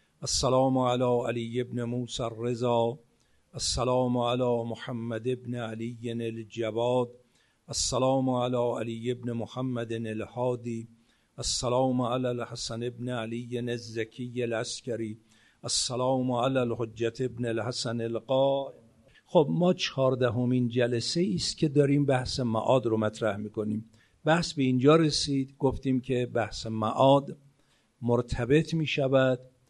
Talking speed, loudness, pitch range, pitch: 115 wpm, -28 LUFS, 115-130 Hz, 125 Hz